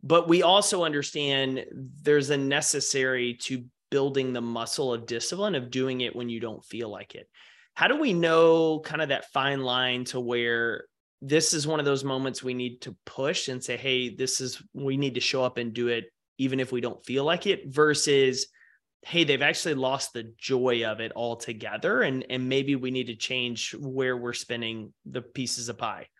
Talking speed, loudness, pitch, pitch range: 200 wpm, -26 LUFS, 130 Hz, 120-145 Hz